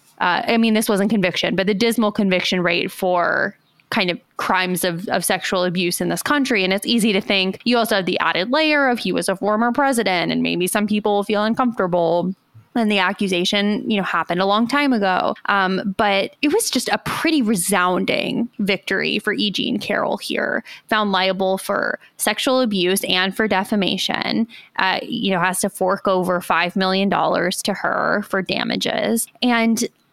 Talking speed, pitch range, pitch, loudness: 185 wpm, 185-225 Hz, 200 Hz, -19 LUFS